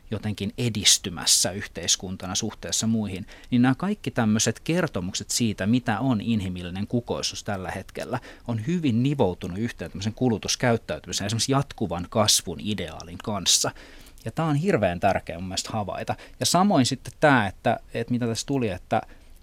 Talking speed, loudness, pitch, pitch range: 140 wpm, -25 LUFS, 110 Hz, 95-125 Hz